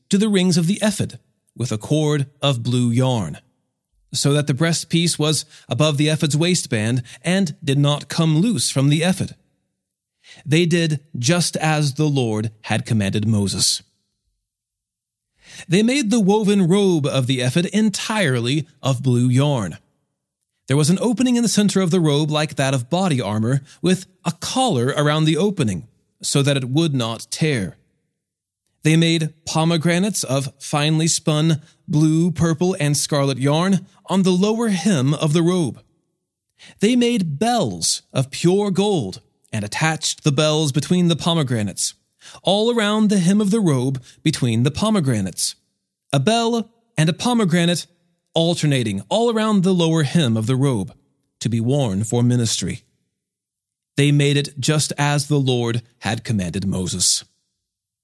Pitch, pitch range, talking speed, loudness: 155 Hz, 130-180 Hz, 150 wpm, -19 LUFS